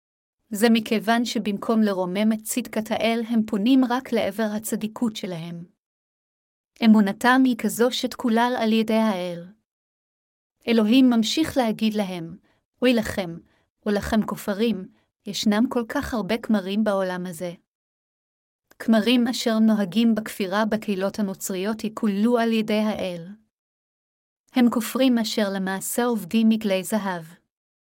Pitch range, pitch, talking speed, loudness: 200-235 Hz, 220 Hz, 115 wpm, -23 LUFS